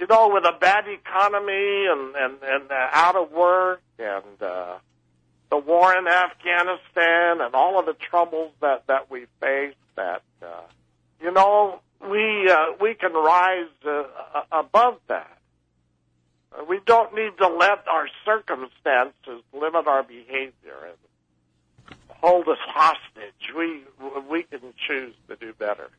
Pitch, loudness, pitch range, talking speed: 160 Hz, -21 LUFS, 125-185 Hz, 140 wpm